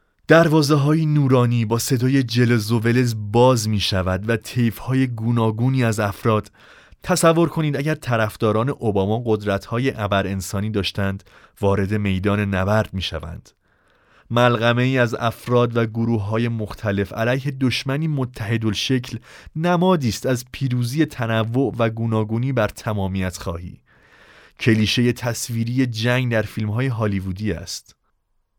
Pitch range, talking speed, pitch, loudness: 105-125 Hz, 125 wpm, 115 Hz, -20 LUFS